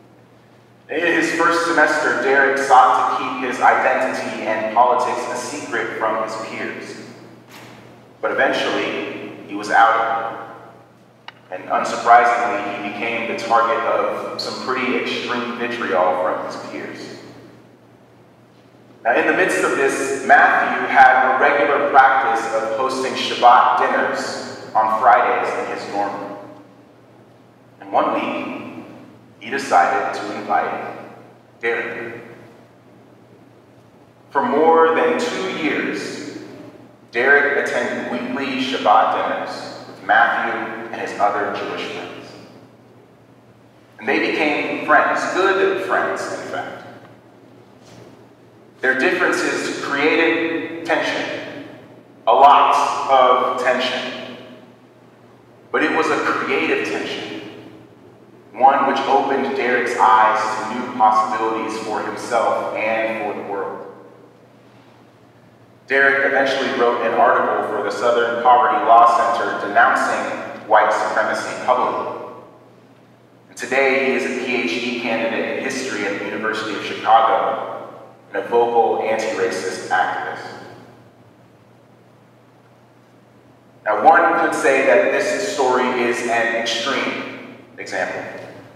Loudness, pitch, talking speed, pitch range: -18 LUFS, 120 Hz, 110 wpm, 110-135 Hz